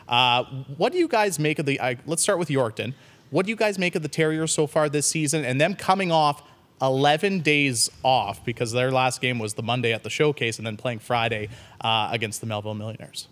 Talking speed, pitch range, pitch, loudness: 230 wpm, 120-155 Hz, 135 Hz, -23 LUFS